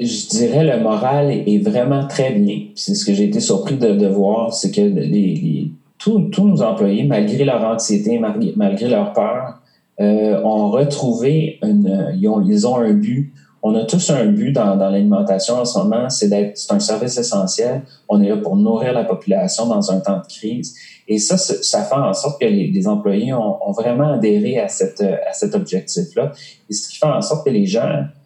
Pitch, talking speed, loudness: 150 Hz, 210 wpm, -17 LUFS